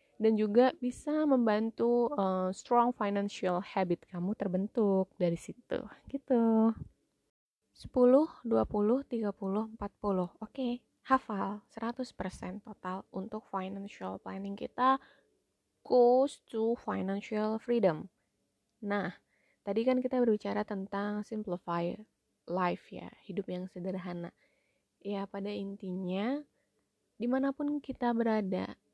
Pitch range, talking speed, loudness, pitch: 190-240 Hz, 100 wpm, -33 LUFS, 210 Hz